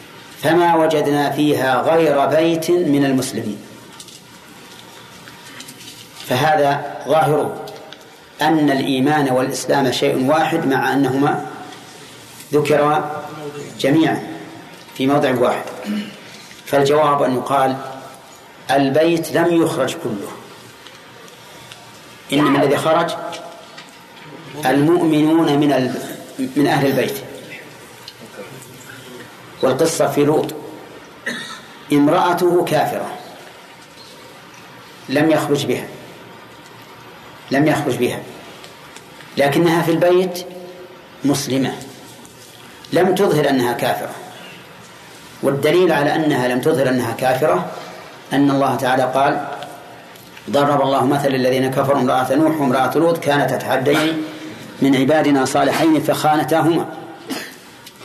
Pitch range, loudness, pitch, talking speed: 135-160 Hz, -17 LUFS, 145 Hz, 85 wpm